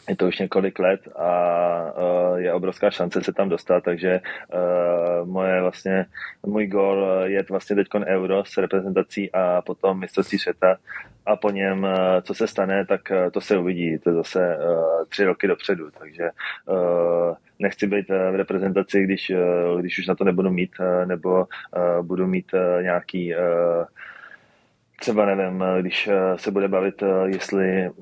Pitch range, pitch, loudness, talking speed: 90-95 Hz, 95 Hz, -22 LUFS, 140 wpm